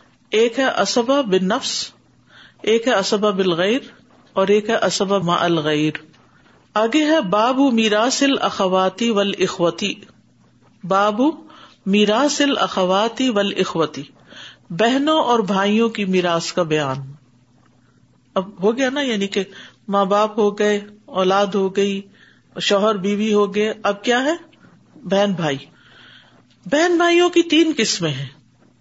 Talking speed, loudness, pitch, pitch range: 135 wpm, -18 LUFS, 205 Hz, 185-235 Hz